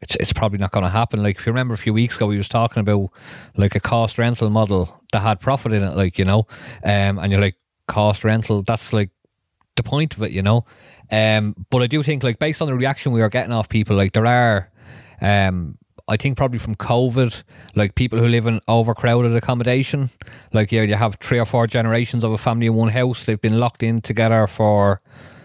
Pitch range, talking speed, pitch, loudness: 105-120 Hz, 230 wpm, 115 Hz, -19 LUFS